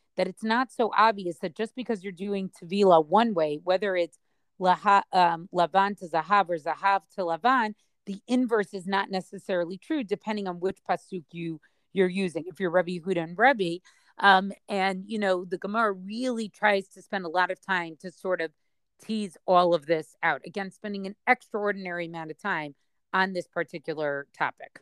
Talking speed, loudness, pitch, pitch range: 185 wpm, -27 LUFS, 190 Hz, 175-205 Hz